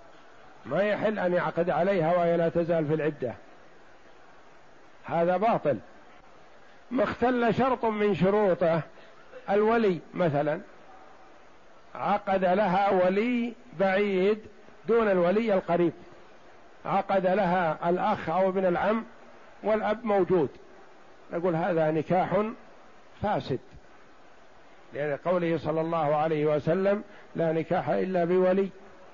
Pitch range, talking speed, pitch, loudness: 165-205 Hz, 100 wpm, 185 Hz, -27 LUFS